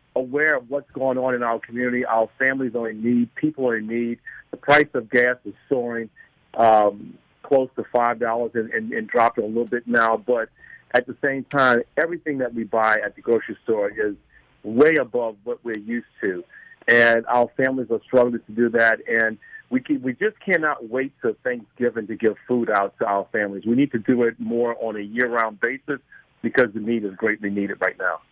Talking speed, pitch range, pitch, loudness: 210 wpm, 115-140 Hz, 120 Hz, -22 LUFS